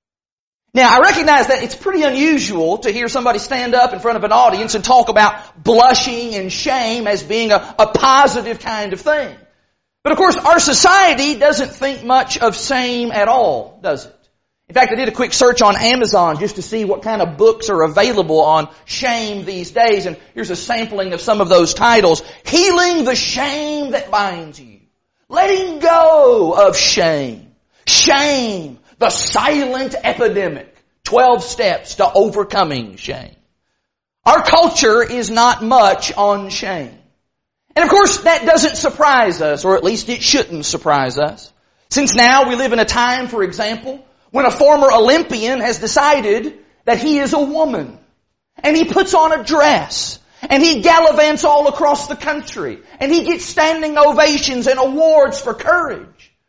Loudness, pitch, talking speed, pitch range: -13 LUFS, 255 Hz, 170 wpm, 215-300 Hz